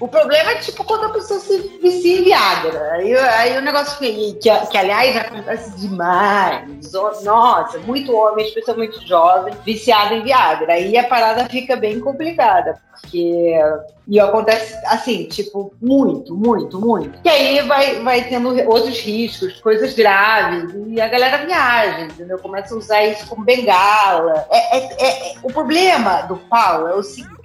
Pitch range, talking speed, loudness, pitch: 200-260 Hz, 160 wpm, -15 LUFS, 225 Hz